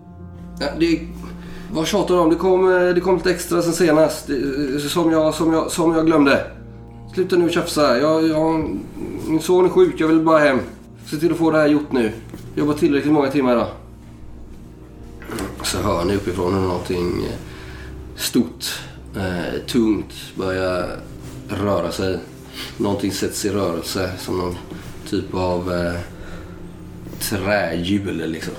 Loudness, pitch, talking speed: -19 LUFS, 140 Hz, 150 wpm